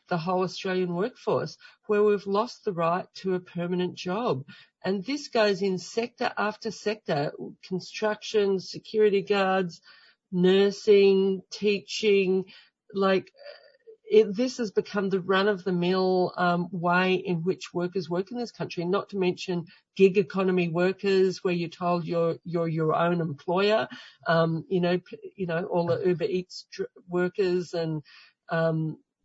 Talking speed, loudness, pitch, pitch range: 140 wpm, -27 LUFS, 185 Hz, 175-205 Hz